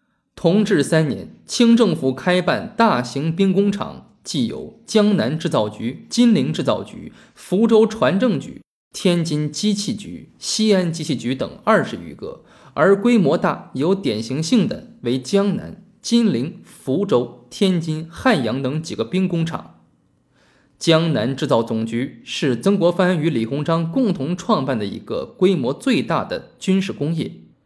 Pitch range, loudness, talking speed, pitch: 150-215 Hz, -19 LUFS, 220 characters per minute, 185 Hz